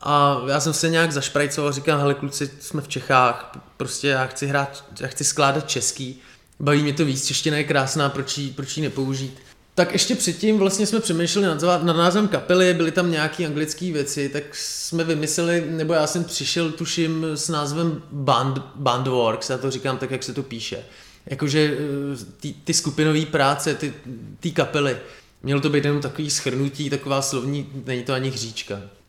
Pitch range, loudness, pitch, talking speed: 135-160 Hz, -22 LUFS, 145 Hz, 180 wpm